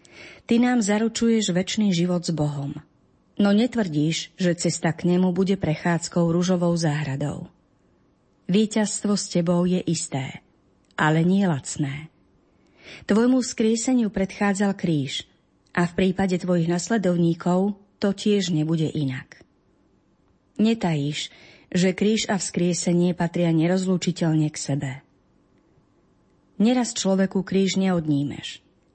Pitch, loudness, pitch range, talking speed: 180 Hz, -23 LUFS, 160-200 Hz, 105 wpm